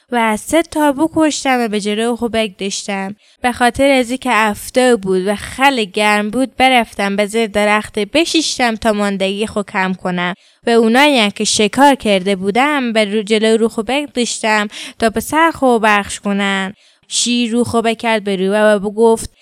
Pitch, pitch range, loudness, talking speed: 225 Hz, 210-255 Hz, -14 LUFS, 165 wpm